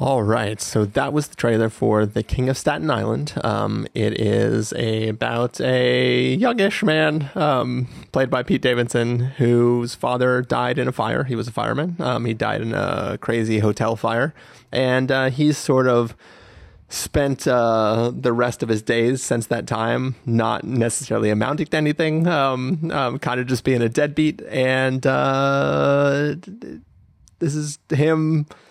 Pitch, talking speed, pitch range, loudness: 125 Hz, 160 wpm, 115-140 Hz, -20 LUFS